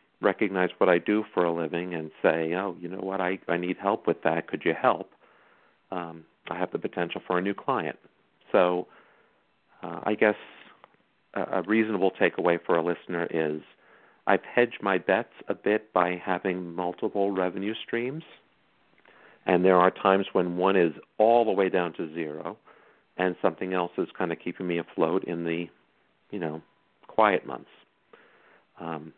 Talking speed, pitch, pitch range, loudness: 170 wpm, 90 Hz, 85-100 Hz, -27 LUFS